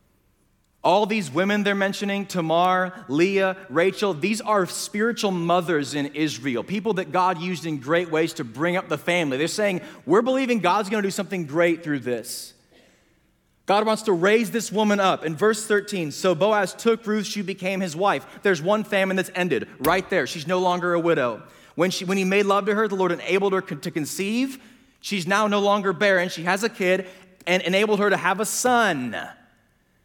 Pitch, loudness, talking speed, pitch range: 190 Hz, -23 LUFS, 195 wpm, 175-205 Hz